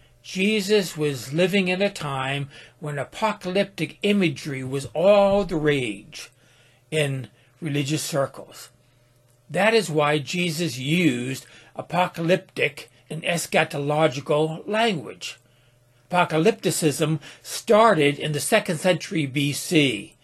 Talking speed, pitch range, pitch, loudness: 95 wpm, 135-180 Hz, 155 Hz, -23 LUFS